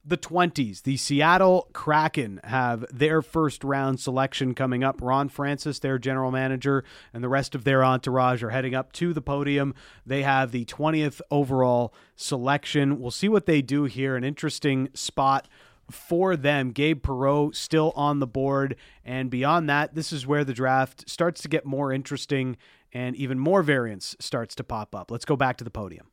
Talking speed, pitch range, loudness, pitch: 180 wpm, 130-150 Hz, -25 LUFS, 135 Hz